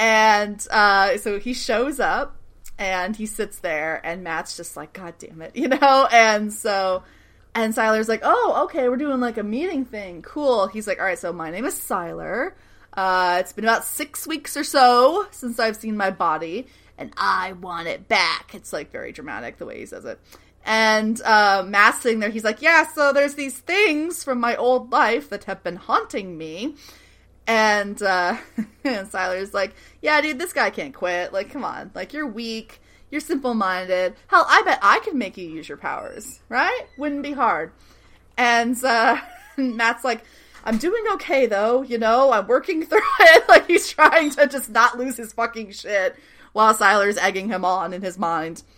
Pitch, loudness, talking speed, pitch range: 230 Hz, -20 LUFS, 195 wpm, 200-285 Hz